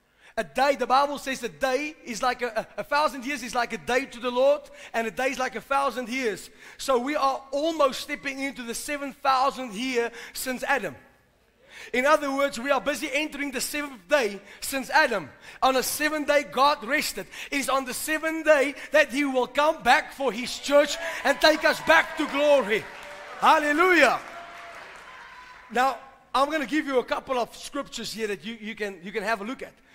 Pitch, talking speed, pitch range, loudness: 270 Hz, 200 wpm, 250-290 Hz, -25 LUFS